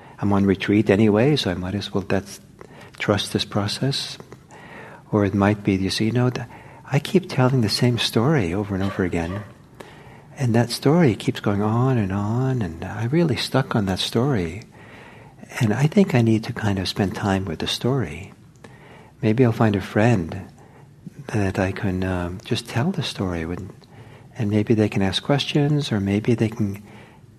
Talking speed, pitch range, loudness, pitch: 185 wpm, 100-130 Hz, -21 LUFS, 110 Hz